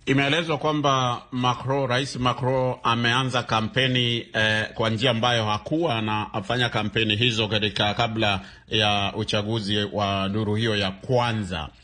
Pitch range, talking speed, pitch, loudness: 105-125 Hz, 125 wpm, 115 Hz, -23 LUFS